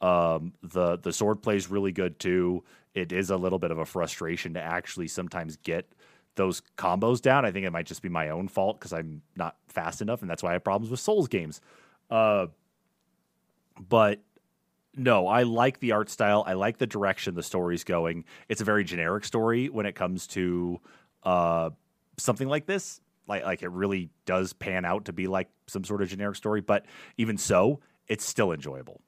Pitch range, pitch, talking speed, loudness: 90-110 Hz, 95 Hz, 195 wpm, -28 LUFS